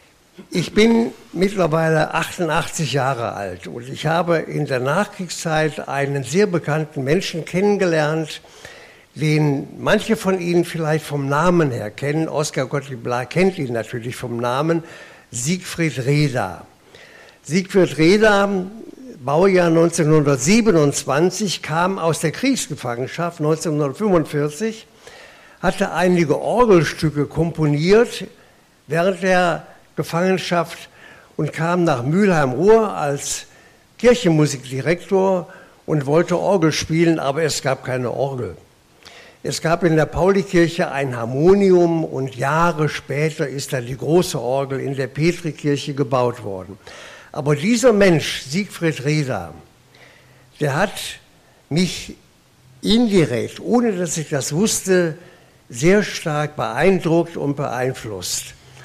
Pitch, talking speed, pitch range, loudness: 160 Hz, 105 wpm, 140-180 Hz, -19 LUFS